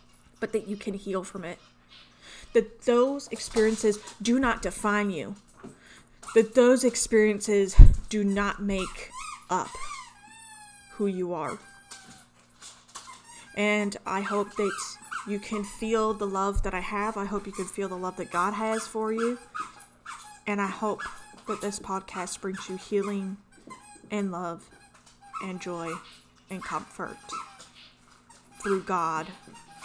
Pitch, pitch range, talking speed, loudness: 205 Hz, 190-220 Hz, 130 wpm, -28 LUFS